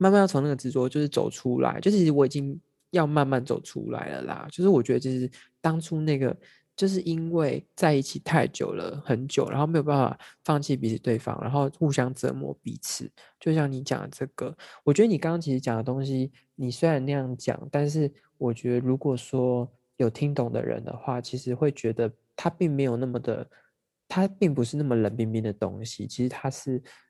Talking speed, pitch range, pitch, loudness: 300 characters per minute, 125-155 Hz, 135 Hz, -27 LUFS